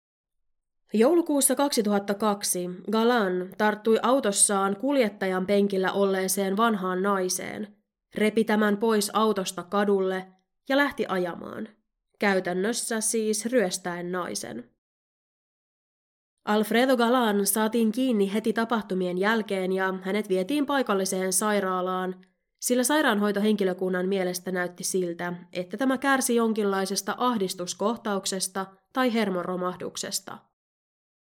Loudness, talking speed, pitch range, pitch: -25 LUFS, 90 wpm, 185-225 Hz, 200 Hz